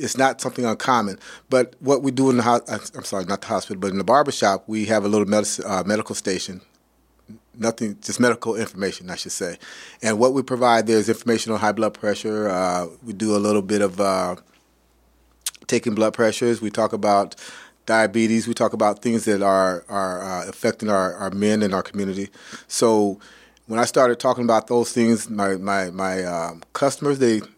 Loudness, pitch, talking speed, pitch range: -21 LUFS, 110 Hz, 195 wpm, 100-115 Hz